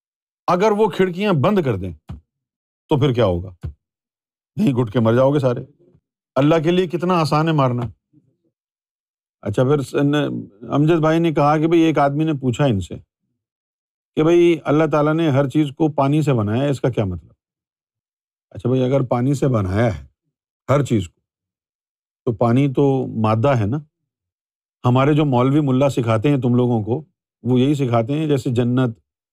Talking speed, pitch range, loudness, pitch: 170 wpm, 120-155 Hz, -18 LUFS, 140 Hz